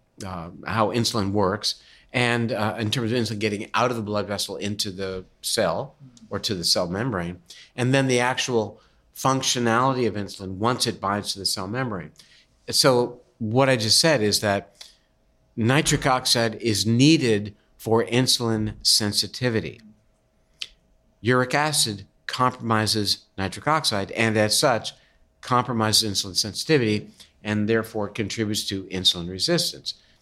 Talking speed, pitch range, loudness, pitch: 135 wpm, 105-125 Hz, -22 LUFS, 110 Hz